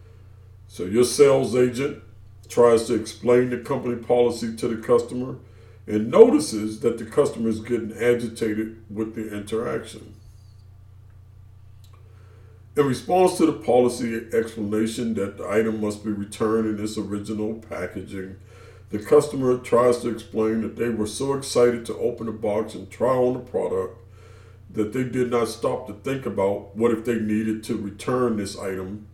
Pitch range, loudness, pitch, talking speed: 100-120 Hz, -23 LUFS, 110 Hz, 155 wpm